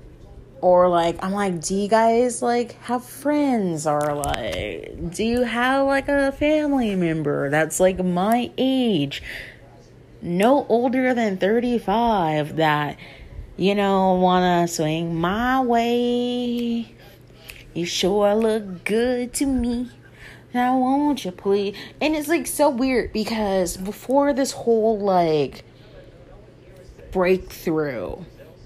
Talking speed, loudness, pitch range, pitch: 115 wpm, -21 LUFS, 170-245 Hz, 205 Hz